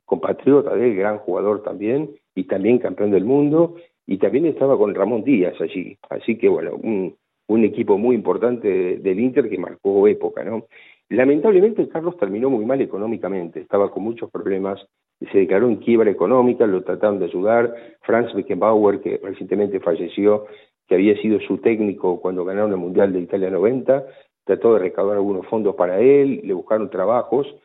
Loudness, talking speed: -19 LUFS, 165 wpm